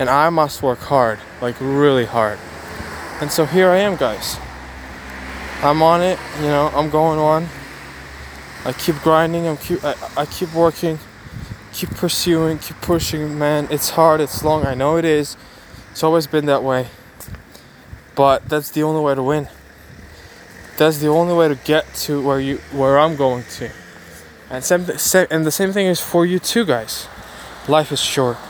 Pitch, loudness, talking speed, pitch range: 145 Hz, -17 LUFS, 175 wpm, 120-160 Hz